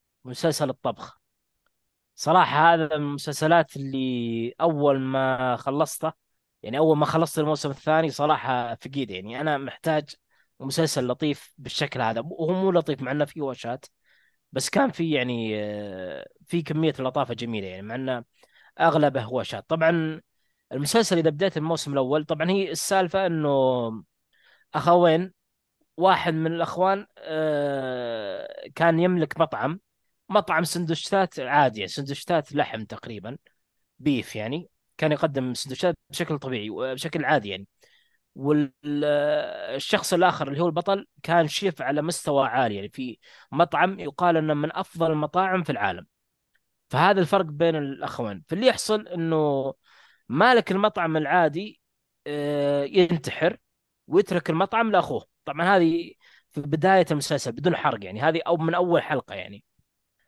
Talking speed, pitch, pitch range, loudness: 125 wpm, 155 Hz, 135-175 Hz, -24 LUFS